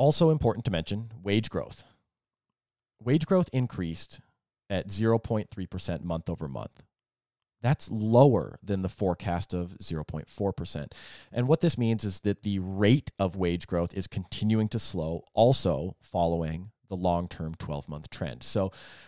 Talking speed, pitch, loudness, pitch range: 135 wpm, 100 Hz, -29 LUFS, 85-115 Hz